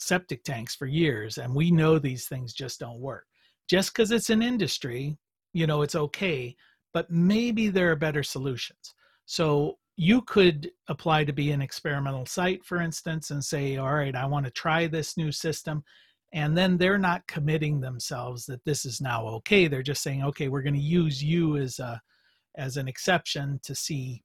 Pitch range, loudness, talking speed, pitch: 135-170 Hz, -27 LUFS, 190 wpm, 150 Hz